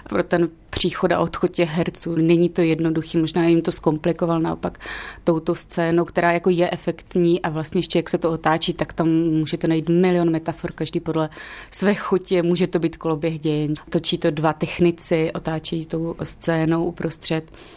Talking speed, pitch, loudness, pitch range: 170 wpm, 170 Hz, -21 LUFS, 160-175 Hz